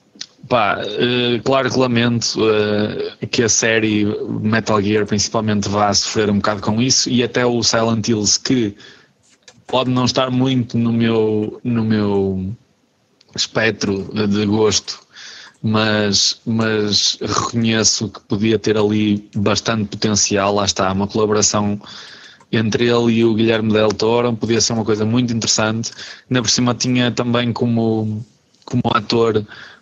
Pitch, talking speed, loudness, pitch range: 110 Hz, 140 wpm, -17 LUFS, 105-120 Hz